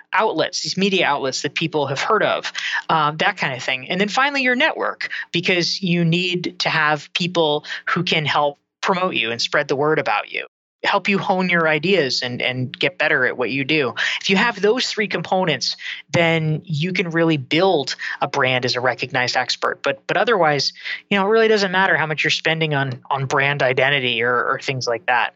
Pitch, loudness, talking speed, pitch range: 160 Hz, -19 LUFS, 210 wpm, 140-190 Hz